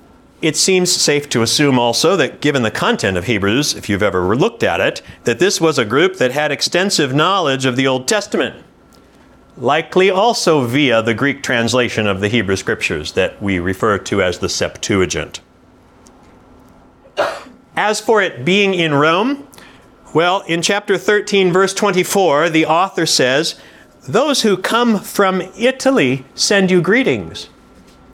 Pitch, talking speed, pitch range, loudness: 160 Hz, 150 wpm, 125-195 Hz, -15 LUFS